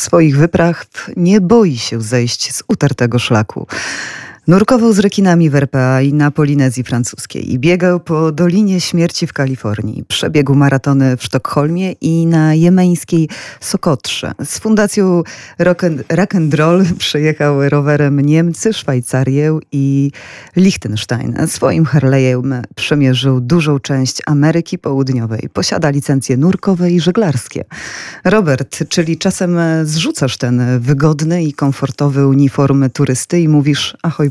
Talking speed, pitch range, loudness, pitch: 120 wpm, 135-175 Hz, -13 LUFS, 150 Hz